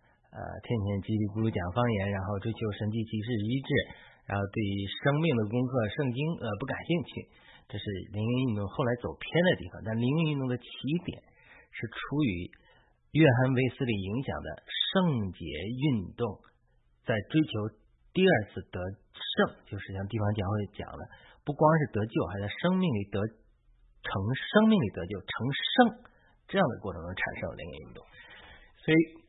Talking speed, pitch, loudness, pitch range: 245 characters per minute, 110 Hz, -30 LUFS, 100-140 Hz